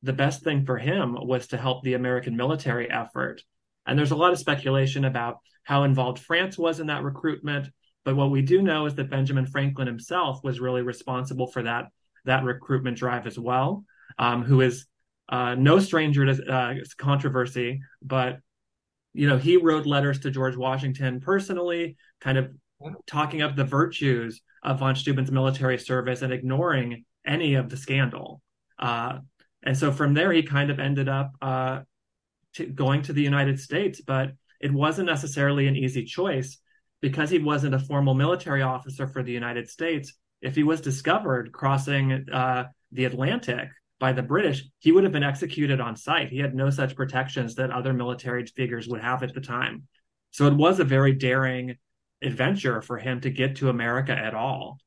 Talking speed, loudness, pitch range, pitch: 180 wpm, -25 LUFS, 125-145 Hz, 135 Hz